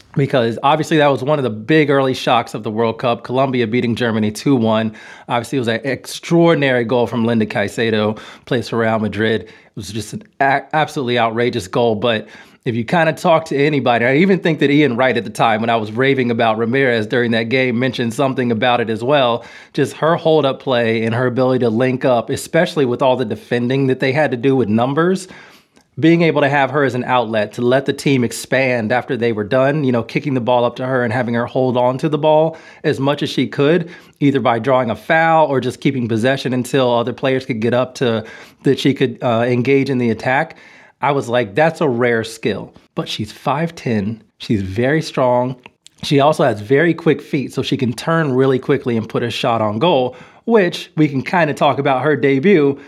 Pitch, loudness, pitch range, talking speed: 130 Hz, -16 LUFS, 120-145 Hz, 225 wpm